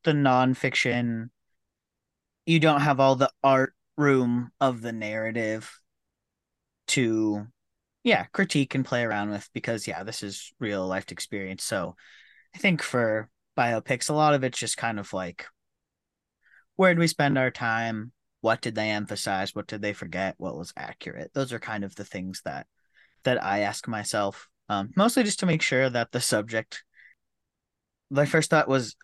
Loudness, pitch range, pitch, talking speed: -26 LUFS, 105-135 Hz, 120 Hz, 165 wpm